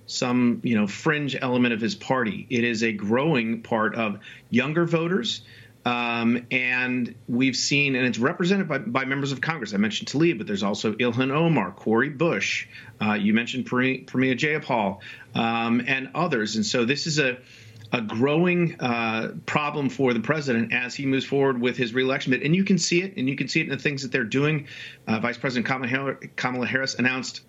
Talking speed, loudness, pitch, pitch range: 190 wpm, -24 LUFS, 130 Hz, 120-145 Hz